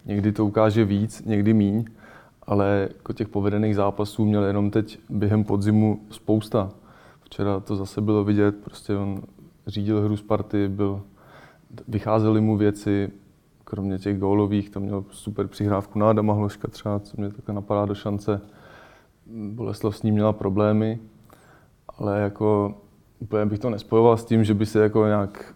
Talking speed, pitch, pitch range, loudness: 155 wpm, 105 Hz, 100-110 Hz, -23 LUFS